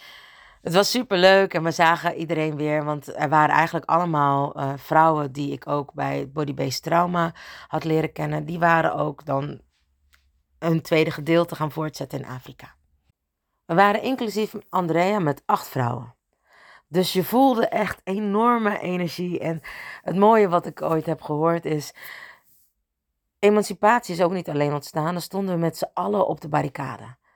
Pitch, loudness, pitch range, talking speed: 160 Hz, -22 LUFS, 145-180 Hz, 160 wpm